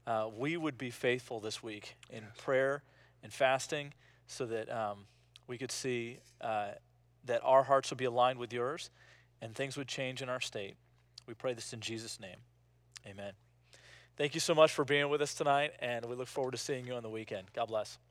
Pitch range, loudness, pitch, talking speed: 115-135 Hz, -35 LUFS, 125 Hz, 200 wpm